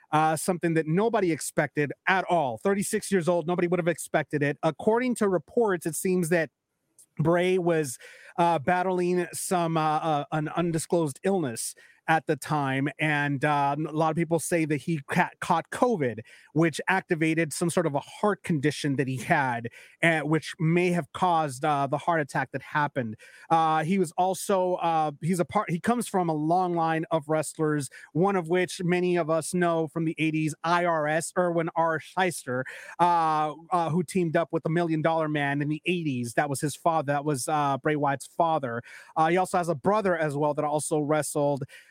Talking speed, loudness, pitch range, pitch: 190 wpm, -26 LUFS, 150-175 Hz, 165 Hz